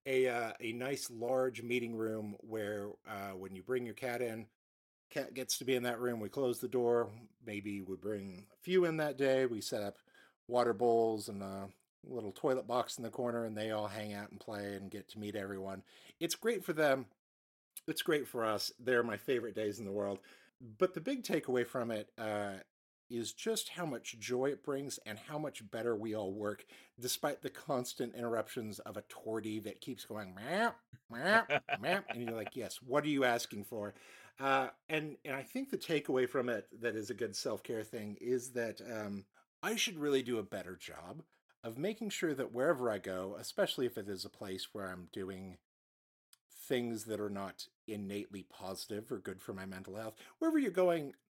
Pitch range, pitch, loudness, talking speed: 105-130 Hz, 115 Hz, -38 LUFS, 200 wpm